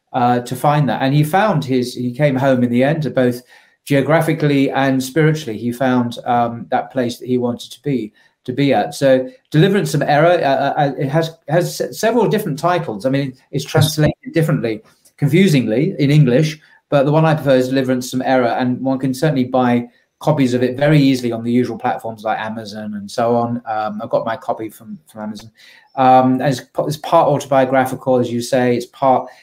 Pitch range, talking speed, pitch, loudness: 120-150 Hz, 200 wpm, 130 Hz, -16 LUFS